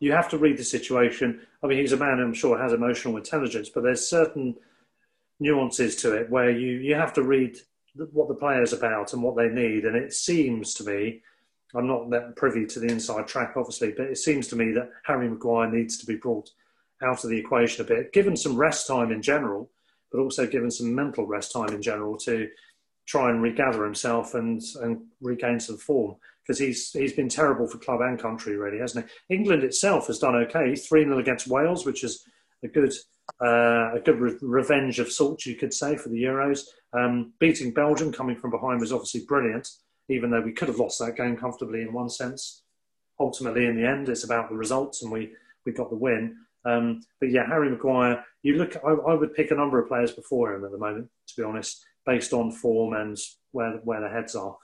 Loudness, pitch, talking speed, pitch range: -26 LUFS, 125 Hz, 220 wpm, 115-140 Hz